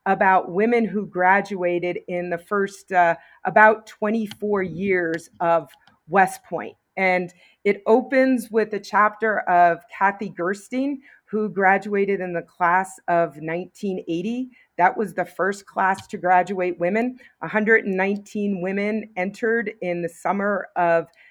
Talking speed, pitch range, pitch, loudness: 125 wpm, 180-215 Hz, 195 Hz, -22 LUFS